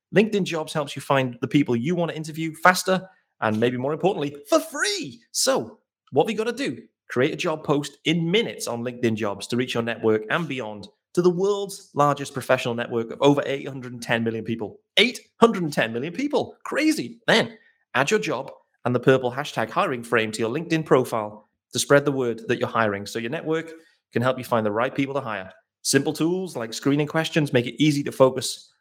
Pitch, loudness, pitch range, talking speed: 140 Hz, -23 LUFS, 120-165 Hz, 205 wpm